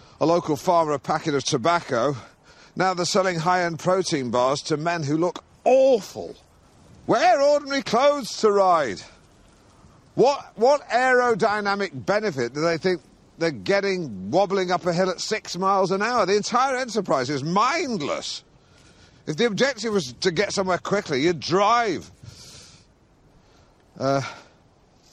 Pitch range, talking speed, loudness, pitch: 160-210 Hz, 135 wpm, -22 LUFS, 185 Hz